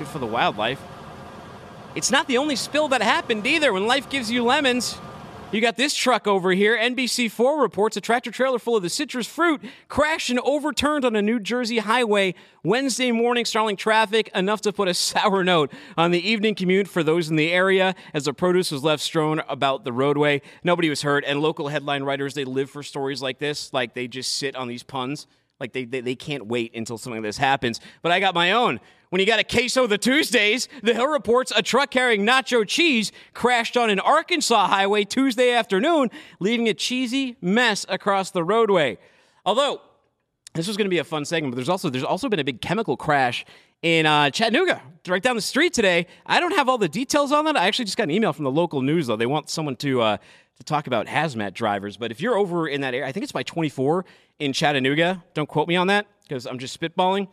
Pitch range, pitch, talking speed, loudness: 145-240 Hz, 195 Hz, 220 wpm, -22 LUFS